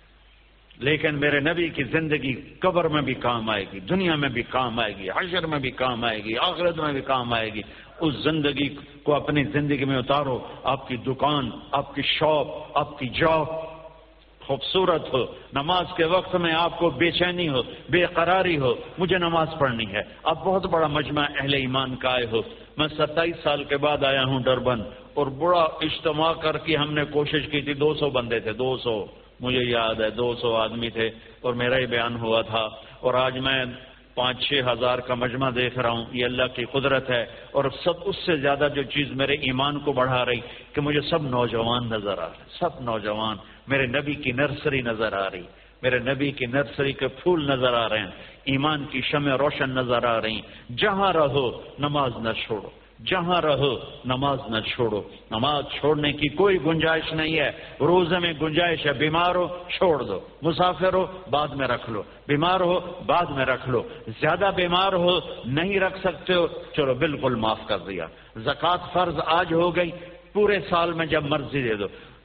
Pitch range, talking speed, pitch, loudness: 125-160 Hz, 190 wpm, 145 Hz, -24 LUFS